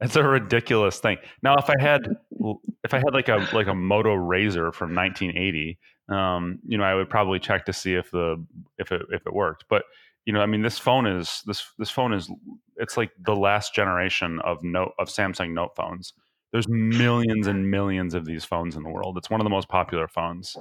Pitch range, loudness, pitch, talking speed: 90-110 Hz, -24 LUFS, 95 Hz, 220 wpm